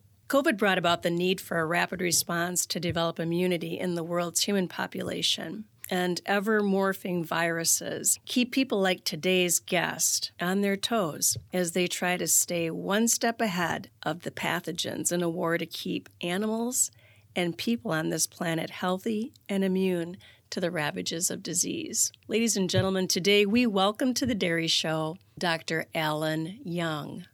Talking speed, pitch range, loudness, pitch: 160 wpm, 165-200 Hz, -27 LUFS, 180 Hz